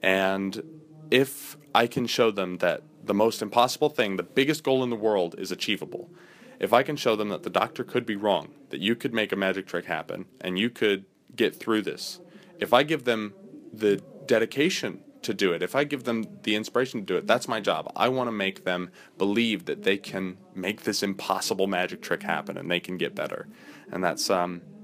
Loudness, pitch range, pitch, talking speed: -27 LUFS, 95-135 Hz, 110 Hz, 215 wpm